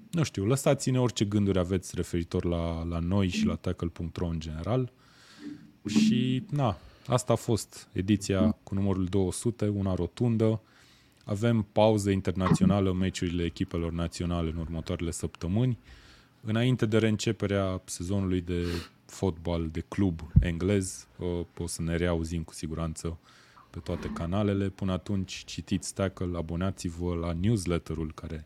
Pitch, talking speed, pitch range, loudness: 95 Hz, 130 wpm, 85-110 Hz, -29 LUFS